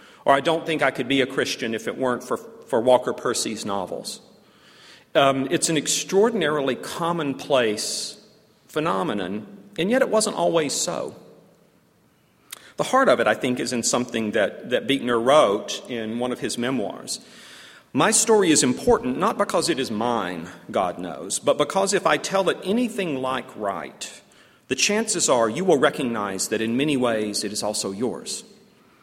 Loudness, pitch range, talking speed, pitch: -22 LUFS, 120-200 Hz, 165 wpm, 150 Hz